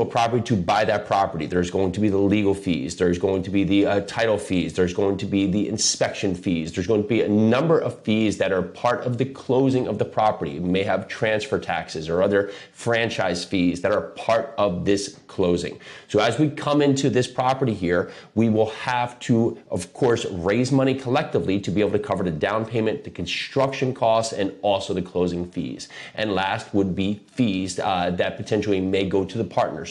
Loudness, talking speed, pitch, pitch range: -23 LUFS, 210 wpm, 105 Hz, 95-120 Hz